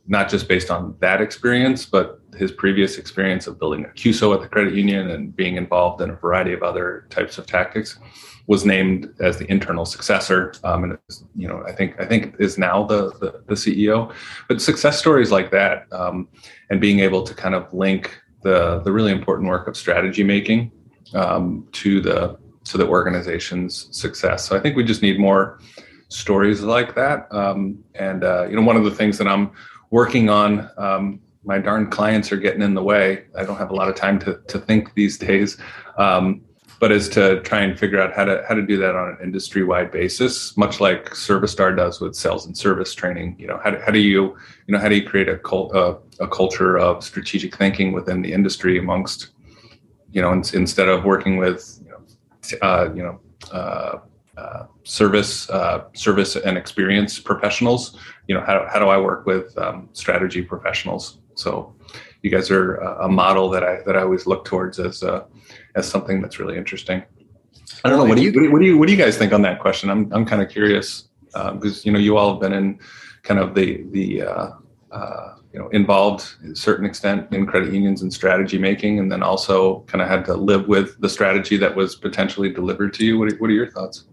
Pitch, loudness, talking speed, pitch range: 100 Hz, -19 LUFS, 215 wpm, 95-105 Hz